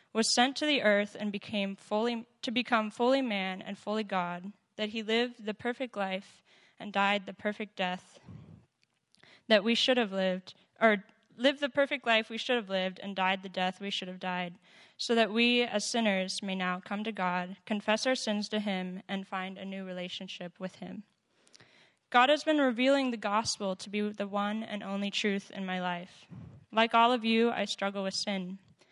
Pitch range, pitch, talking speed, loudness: 190-230 Hz, 205 Hz, 195 wpm, -31 LUFS